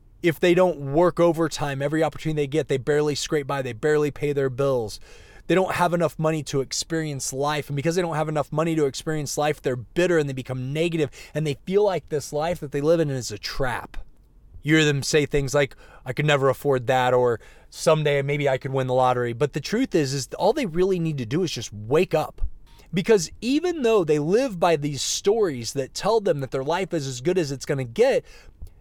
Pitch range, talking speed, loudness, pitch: 135-170 Hz, 230 wpm, -23 LUFS, 150 Hz